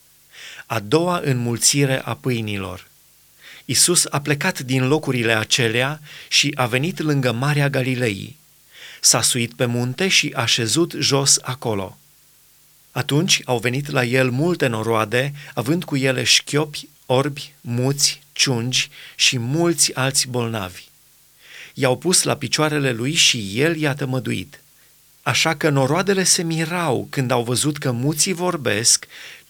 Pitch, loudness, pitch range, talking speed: 140 Hz, -19 LUFS, 125-150 Hz, 130 wpm